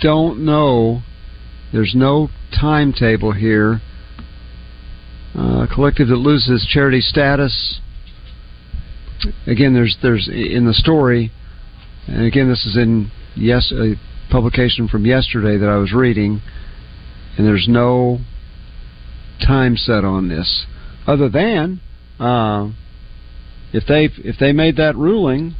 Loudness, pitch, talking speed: -15 LUFS, 115 Hz, 115 wpm